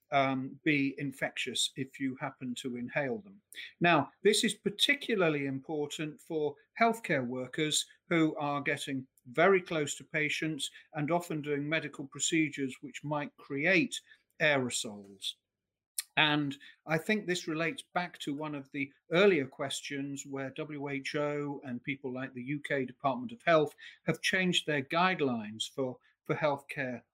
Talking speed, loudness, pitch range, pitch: 135 wpm, -32 LUFS, 135-165 Hz, 145 Hz